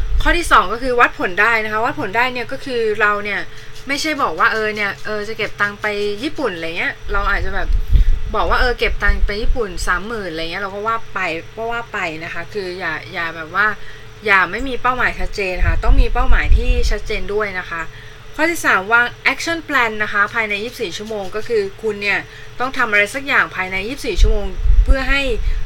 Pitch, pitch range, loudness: 215 Hz, 200-240 Hz, -18 LUFS